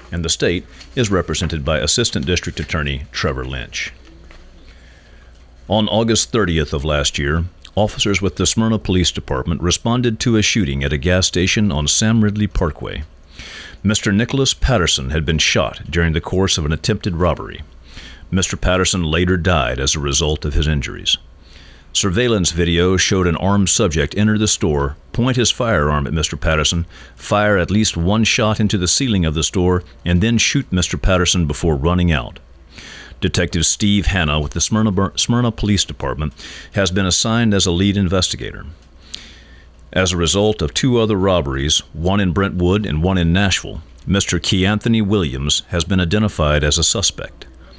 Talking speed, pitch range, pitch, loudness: 165 wpm, 75-100 Hz, 90 Hz, -17 LUFS